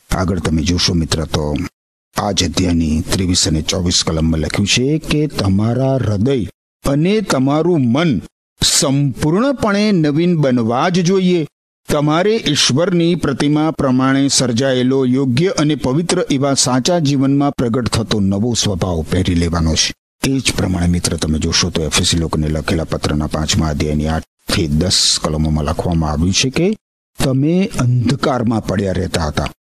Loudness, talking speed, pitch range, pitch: -15 LUFS, 135 wpm, 85-145 Hz, 120 Hz